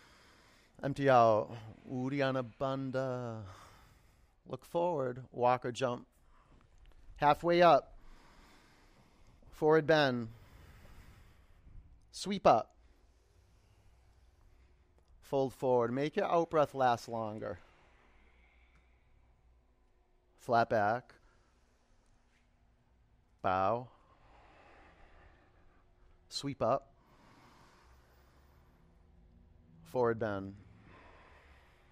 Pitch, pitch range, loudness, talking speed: 100 Hz, 80-125 Hz, -32 LUFS, 55 wpm